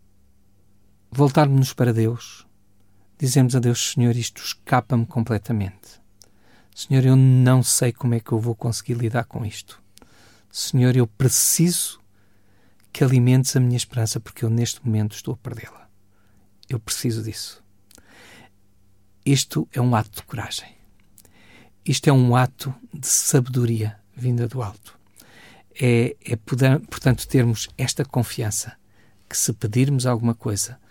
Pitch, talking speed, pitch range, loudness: 120 Hz, 130 wpm, 105-130 Hz, -21 LUFS